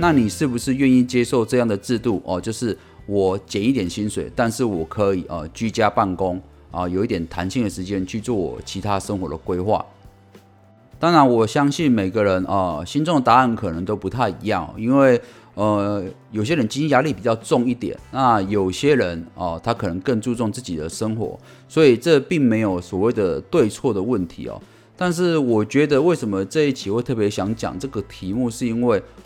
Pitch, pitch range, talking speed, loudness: 105 Hz, 95-125 Hz, 295 characters per minute, -20 LUFS